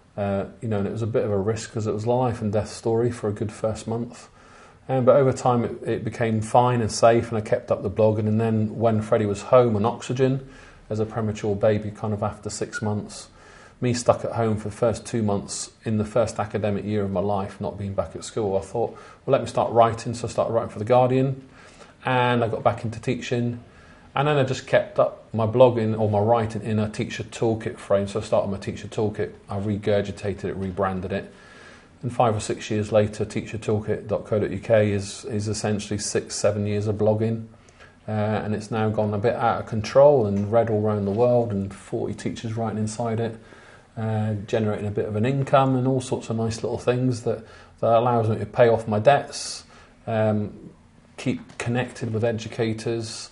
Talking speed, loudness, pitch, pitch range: 215 wpm, -24 LUFS, 110 Hz, 105-120 Hz